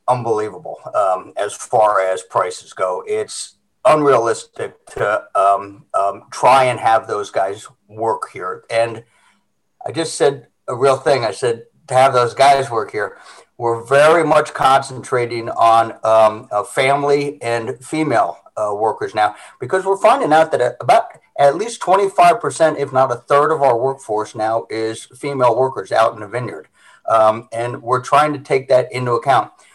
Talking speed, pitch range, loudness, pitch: 160 wpm, 115-160 Hz, -16 LUFS, 135 Hz